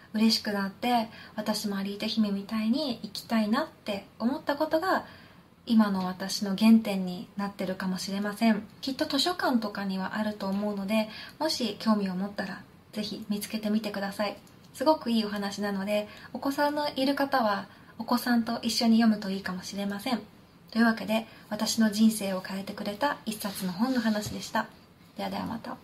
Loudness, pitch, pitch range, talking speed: -29 LUFS, 215 Hz, 200-235 Hz, 360 characters per minute